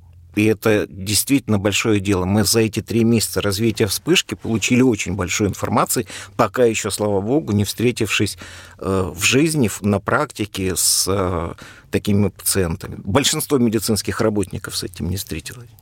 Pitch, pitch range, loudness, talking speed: 105 Hz, 95-115 Hz, -19 LUFS, 135 wpm